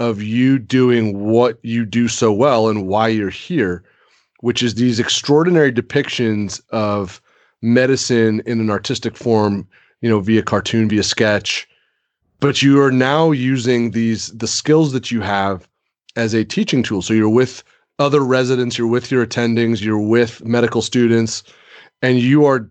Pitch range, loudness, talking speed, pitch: 110-125 Hz, -16 LUFS, 160 wpm, 115 Hz